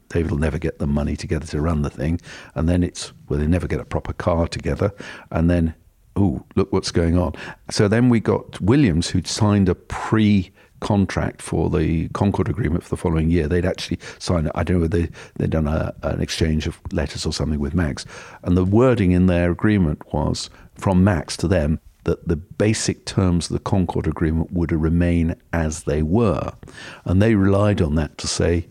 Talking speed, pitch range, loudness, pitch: 200 wpm, 80-95 Hz, -21 LUFS, 85 Hz